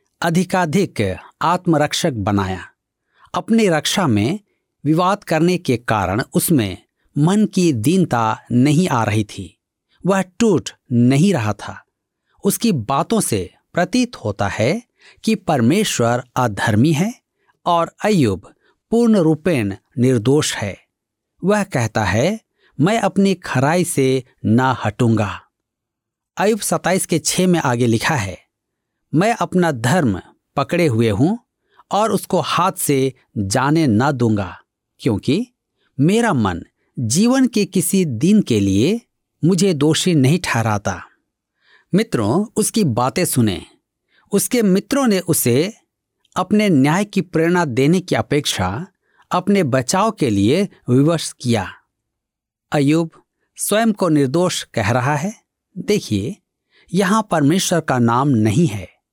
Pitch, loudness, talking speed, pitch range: 155 Hz, -17 LUFS, 120 wpm, 120-190 Hz